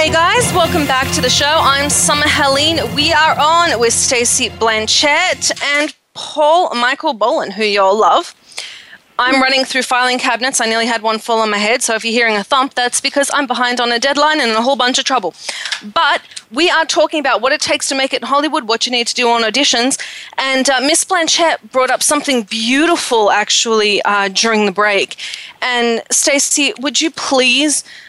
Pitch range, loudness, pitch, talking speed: 235-300 Hz, -13 LUFS, 265 Hz, 205 wpm